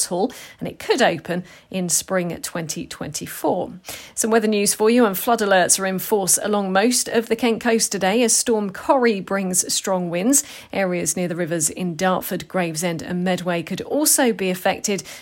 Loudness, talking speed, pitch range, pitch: -20 LUFS, 180 wpm, 180-225 Hz, 190 Hz